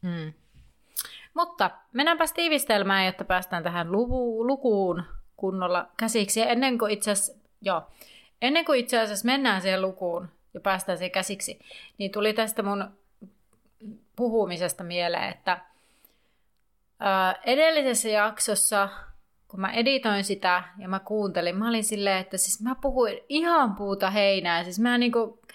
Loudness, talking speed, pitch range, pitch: -26 LUFS, 130 wpm, 190-235 Hz, 210 Hz